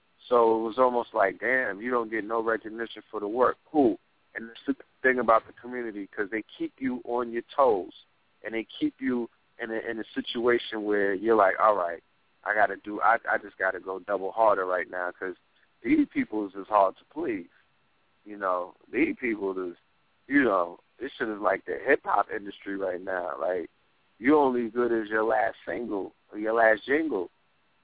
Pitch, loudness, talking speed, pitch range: 115 Hz, -27 LUFS, 200 wpm, 105-125 Hz